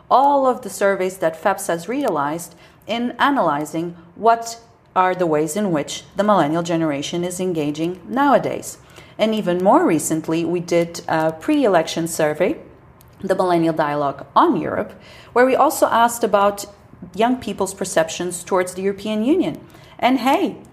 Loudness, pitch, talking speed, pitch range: -19 LUFS, 185 Hz, 145 wpm, 165-215 Hz